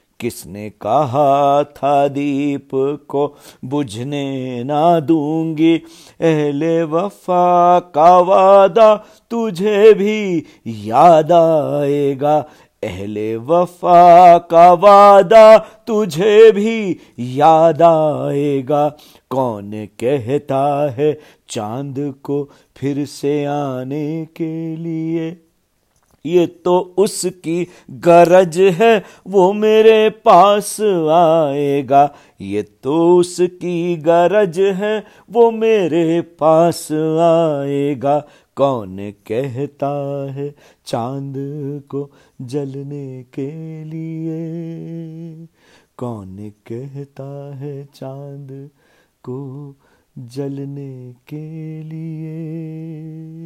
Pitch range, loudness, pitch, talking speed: 140-175 Hz, -14 LUFS, 155 Hz, 75 wpm